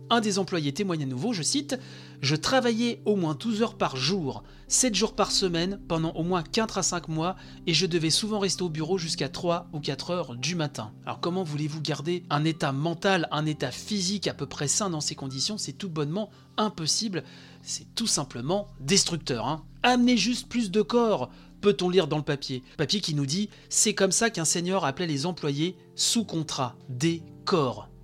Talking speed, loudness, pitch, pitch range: 200 wpm, -27 LUFS, 175 Hz, 150-205 Hz